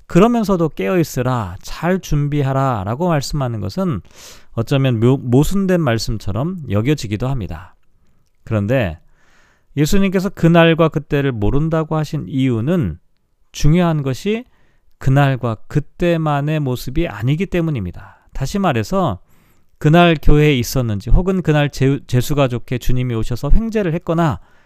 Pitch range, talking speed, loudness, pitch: 115-165 Hz, 295 characters per minute, -17 LUFS, 140 Hz